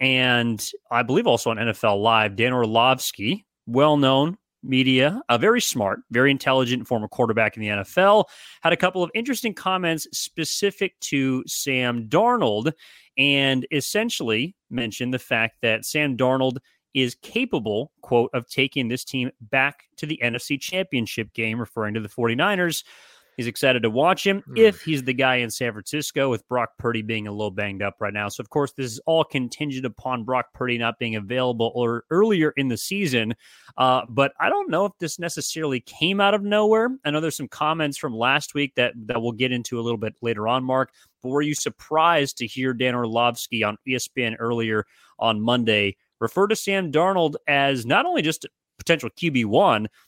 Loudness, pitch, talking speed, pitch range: -22 LUFS, 130 Hz, 185 wpm, 115-155 Hz